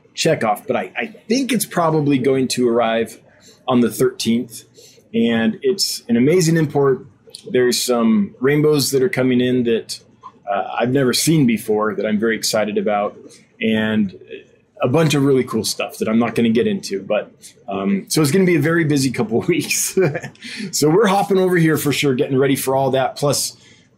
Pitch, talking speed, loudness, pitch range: 135 Hz, 195 wpm, -18 LUFS, 120-170 Hz